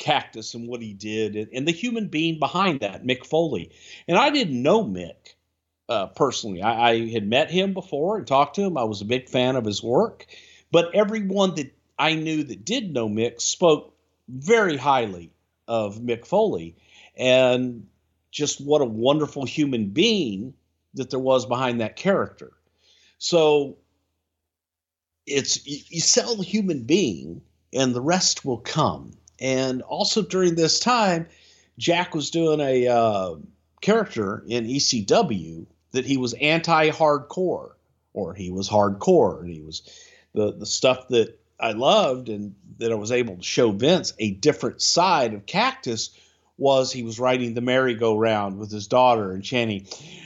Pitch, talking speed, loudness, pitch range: 125 Hz, 160 wpm, -22 LUFS, 110-160 Hz